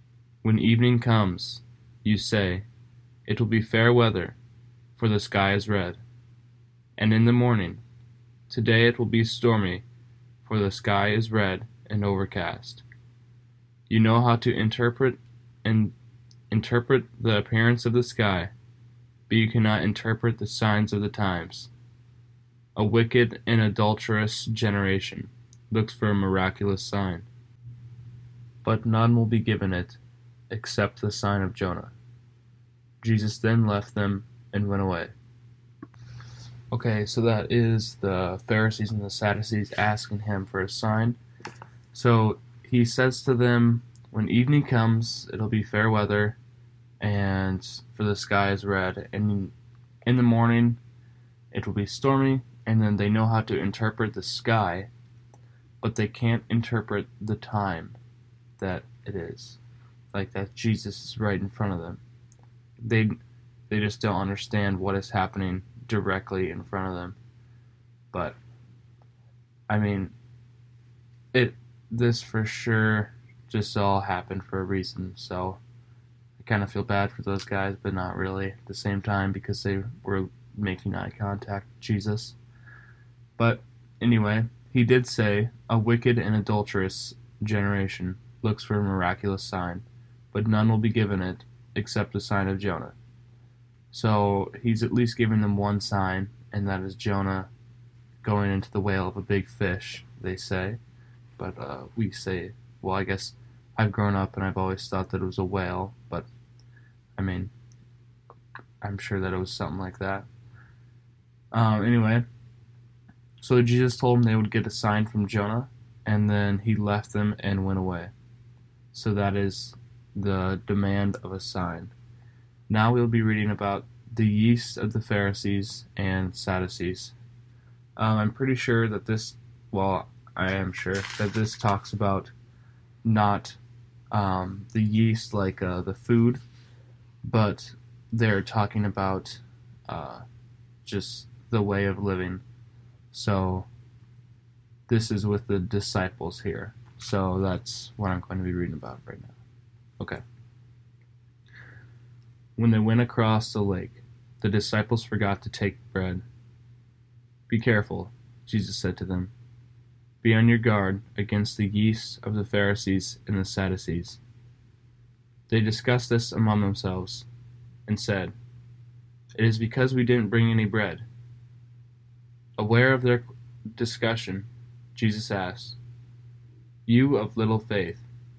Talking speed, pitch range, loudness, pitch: 140 wpm, 100-120 Hz, -26 LUFS, 115 Hz